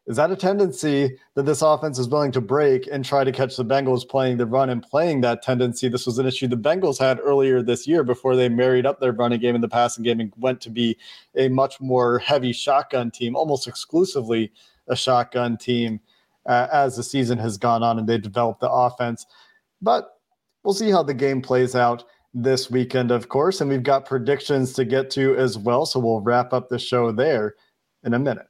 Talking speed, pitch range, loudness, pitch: 215 wpm, 120-135 Hz, -21 LUFS, 125 Hz